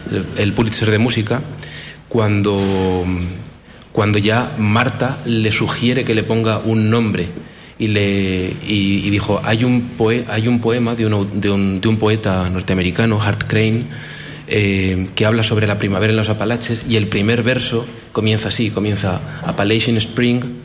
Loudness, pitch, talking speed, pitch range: -17 LUFS, 110 Hz, 155 wpm, 100-115 Hz